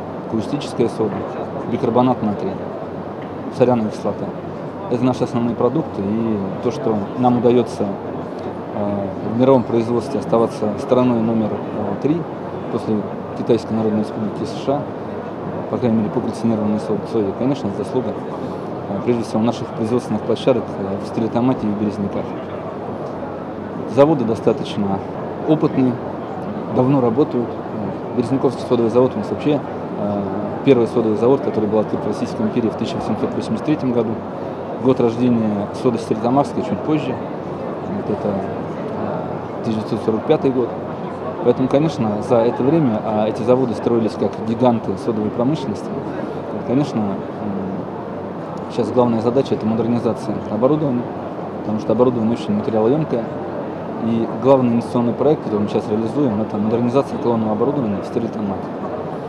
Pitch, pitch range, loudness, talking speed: 115 Hz, 110-125 Hz, -20 LUFS, 115 wpm